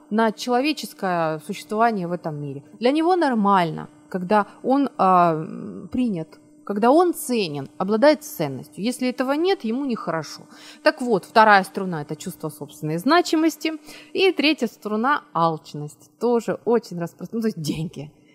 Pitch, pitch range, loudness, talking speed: 210 Hz, 165-255 Hz, -22 LUFS, 135 wpm